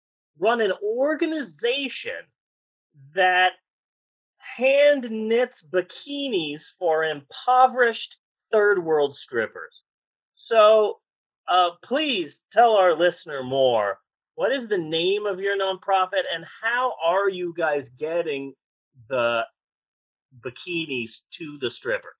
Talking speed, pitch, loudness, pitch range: 100 wpm, 190 Hz, -23 LUFS, 160-245 Hz